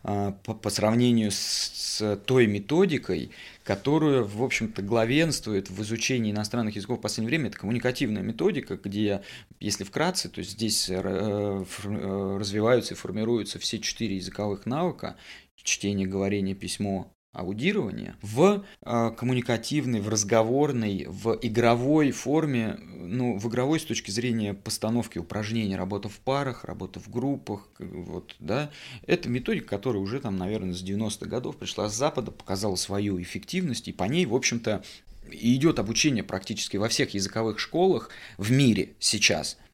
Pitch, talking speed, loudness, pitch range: 110 Hz, 135 wpm, -27 LUFS, 100-125 Hz